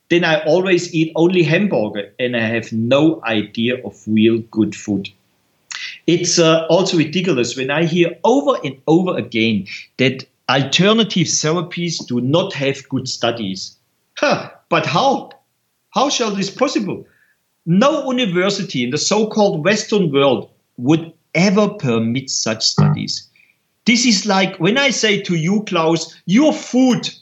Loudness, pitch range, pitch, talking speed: -16 LUFS, 125-195 Hz, 160 Hz, 140 wpm